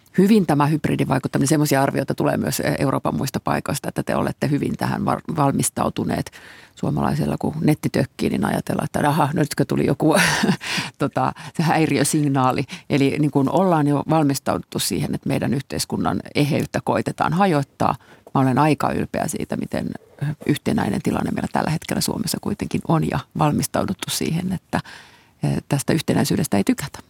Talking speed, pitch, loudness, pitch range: 140 wpm, 145 Hz, -21 LUFS, 135-160 Hz